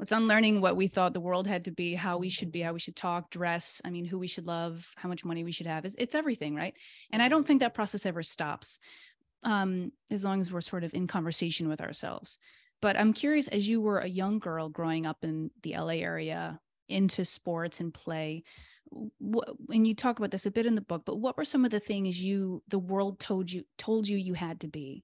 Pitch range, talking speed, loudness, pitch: 170-215 Hz, 245 wpm, -31 LUFS, 185 Hz